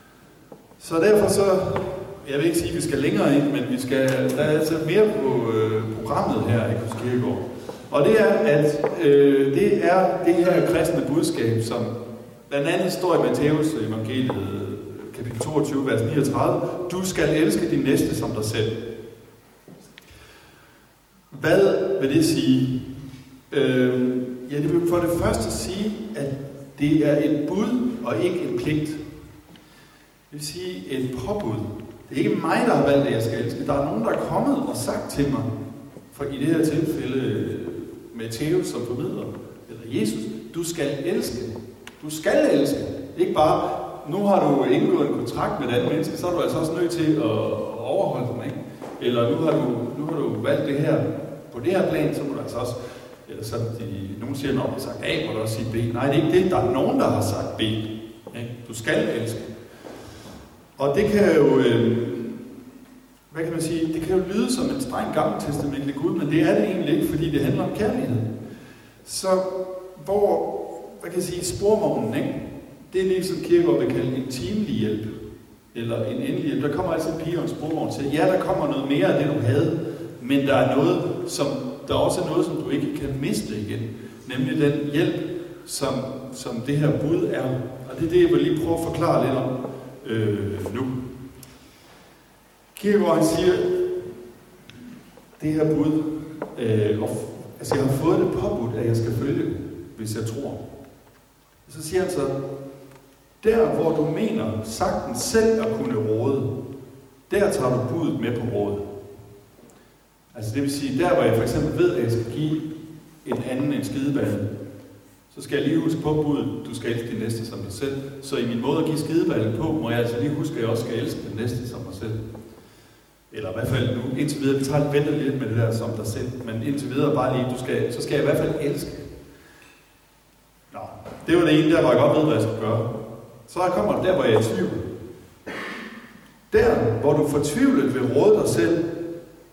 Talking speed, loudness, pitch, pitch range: 195 wpm, -23 LUFS, 140 Hz, 120-160 Hz